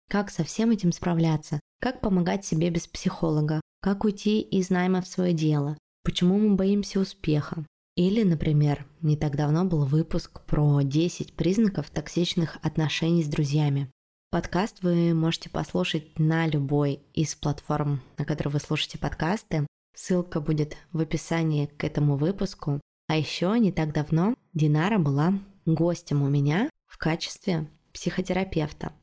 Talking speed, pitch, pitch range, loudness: 140 wpm, 165 Hz, 150-180 Hz, -26 LUFS